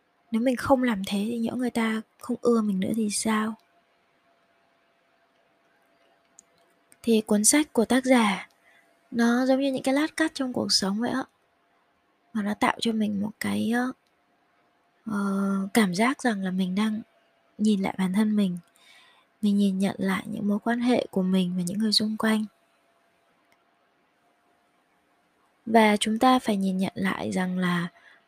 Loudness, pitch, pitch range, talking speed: -25 LUFS, 220 Hz, 200-240 Hz, 160 wpm